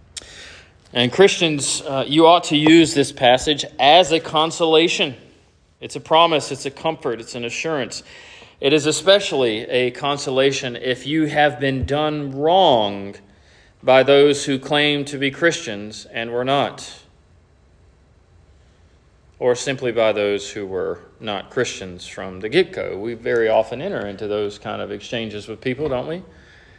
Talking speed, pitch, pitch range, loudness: 150 wpm, 130 Hz, 105-150 Hz, -18 LUFS